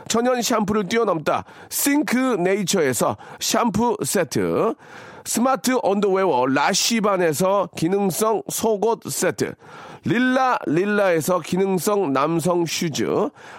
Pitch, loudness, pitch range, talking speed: 210 Hz, -20 LUFS, 190-235 Hz, 230 characters per minute